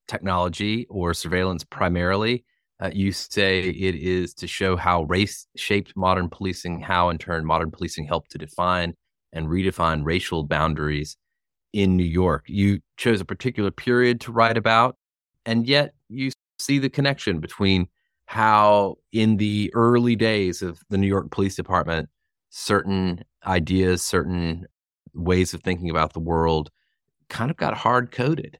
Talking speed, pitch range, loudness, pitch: 150 wpm, 85-105 Hz, -23 LUFS, 95 Hz